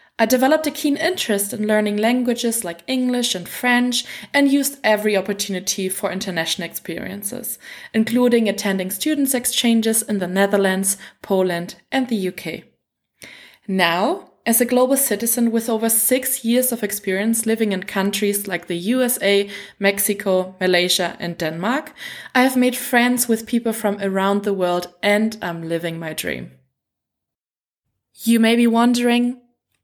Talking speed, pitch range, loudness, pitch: 140 wpm, 190-245 Hz, -19 LUFS, 215 Hz